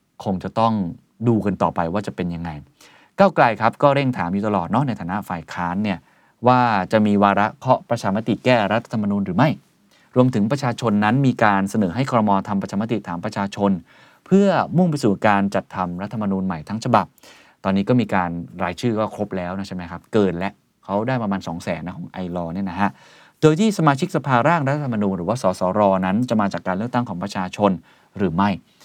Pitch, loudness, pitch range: 100 Hz, -20 LUFS, 95-120 Hz